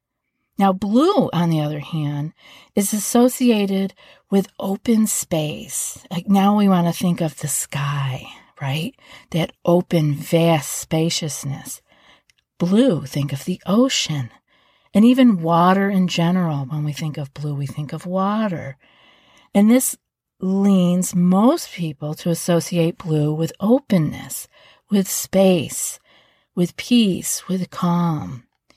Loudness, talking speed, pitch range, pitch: -19 LUFS, 125 wpm, 155-200 Hz, 175 Hz